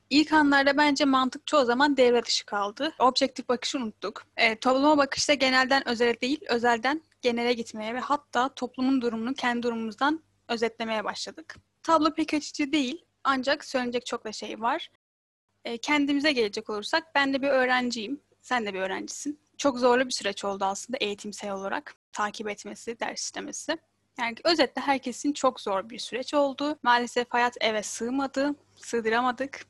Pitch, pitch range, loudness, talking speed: 255 Hz, 235-285 Hz, -26 LUFS, 155 wpm